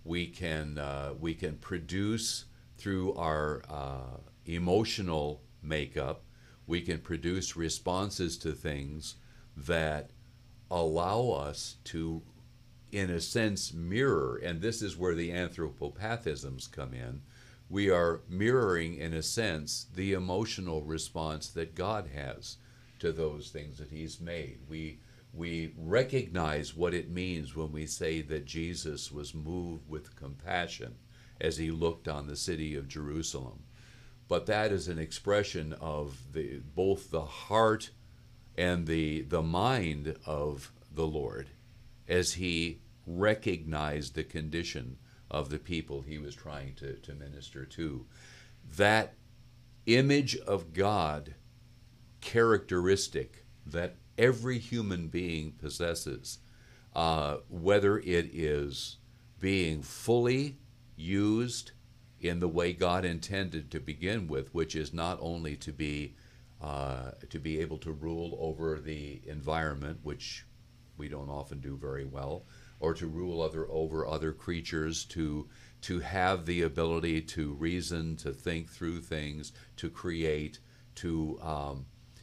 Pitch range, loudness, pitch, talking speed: 75-100 Hz, -34 LUFS, 85 Hz, 130 wpm